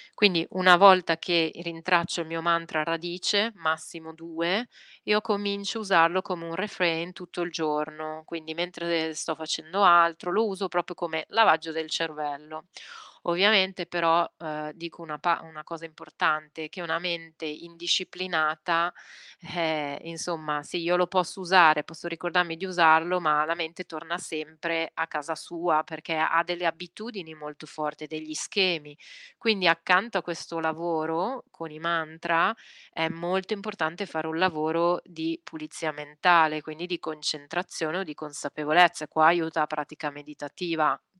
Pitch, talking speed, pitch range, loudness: 165 Hz, 150 wpm, 155-175 Hz, -26 LUFS